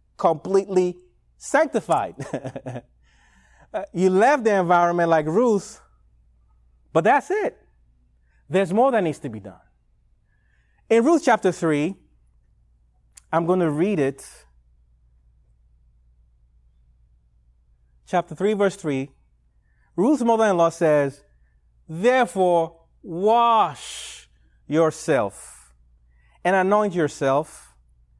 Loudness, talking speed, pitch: -21 LUFS, 90 wpm, 135 Hz